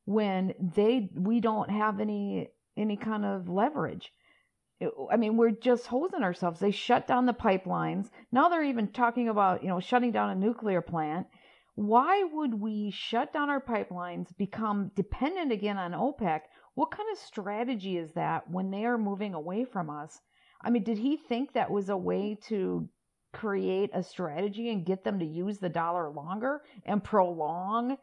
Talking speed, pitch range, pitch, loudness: 175 wpm, 185-240 Hz, 210 Hz, -30 LUFS